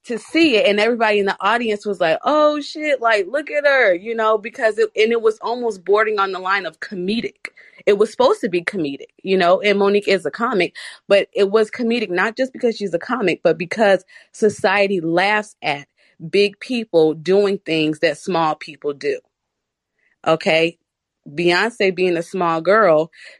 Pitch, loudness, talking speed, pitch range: 205 Hz, -18 LUFS, 185 wpm, 180-235 Hz